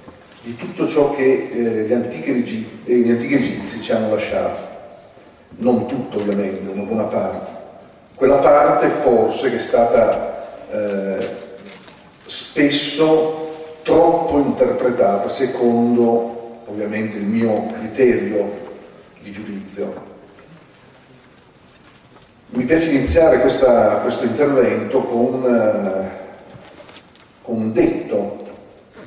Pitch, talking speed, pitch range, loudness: 120 Hz, 95 wpm, 105-130 Hz, -17 LUFS